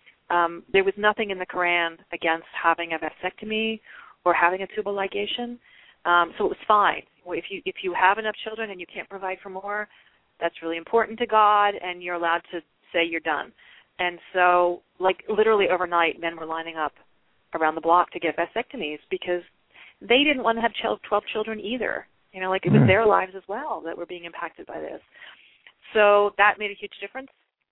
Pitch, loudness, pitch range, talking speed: 185 Hz, -24 LUFS, 170-210 Hz, 195 wpm